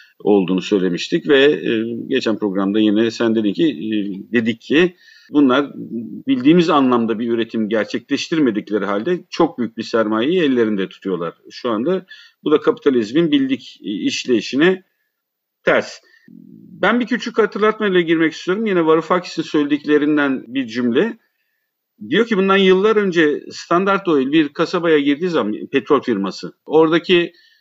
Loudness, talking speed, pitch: -17 LUFS, 125 wpm, 165 Hz